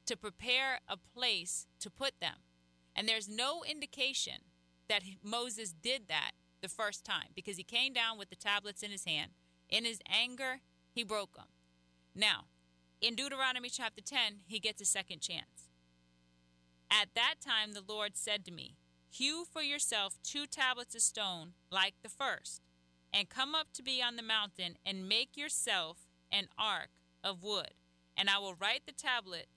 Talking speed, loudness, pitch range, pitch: 170 wpm, -36 LUFS, 150-240 Hz, 205 Hz